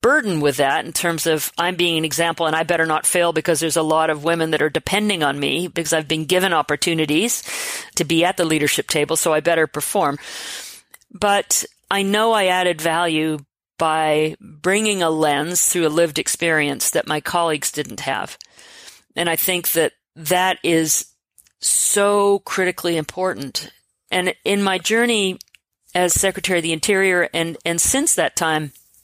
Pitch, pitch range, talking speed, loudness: 170 Hz, 155-185 Hz, 170 wpm, -18 LUFS